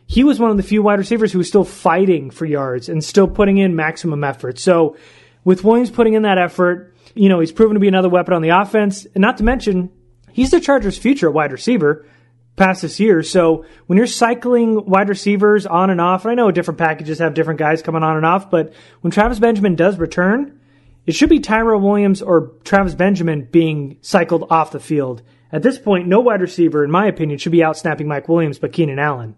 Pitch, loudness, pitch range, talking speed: 180 Hz, -15 LUFS, 160-210 Hz, 225 wpm